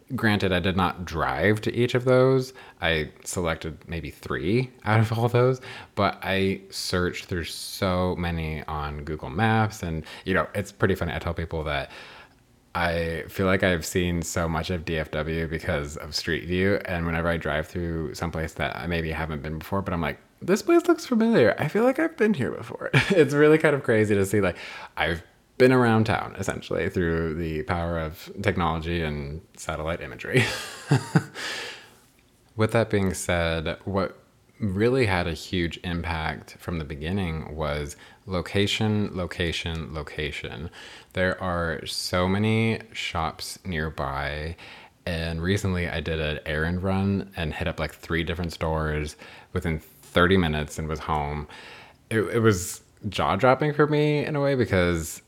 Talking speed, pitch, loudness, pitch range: 165 wpm, 90 Hz, -25 LUFS, 80-105 Hz